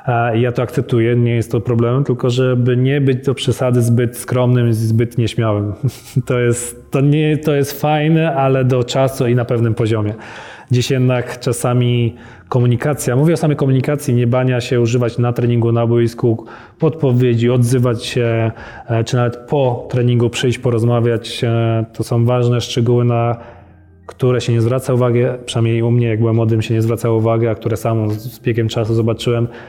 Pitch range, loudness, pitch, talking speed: 115-125 Hz, -16 LUFS, 120 Hz, 170 wpm